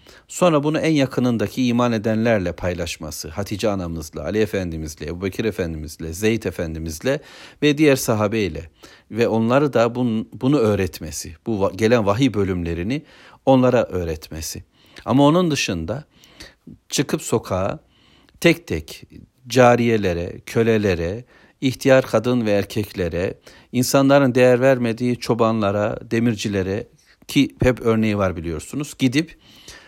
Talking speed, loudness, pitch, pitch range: 105 wpm, -20 LUFS, 110 Hz, 95-125 Hz